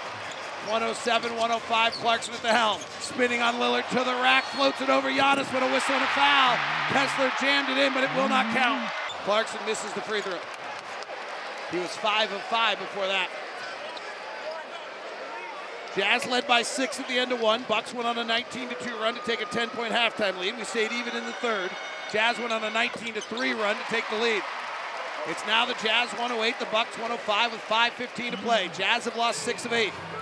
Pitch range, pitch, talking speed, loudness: 220-245 Hz, 235 Hz, 195 wpm, -26 LUFS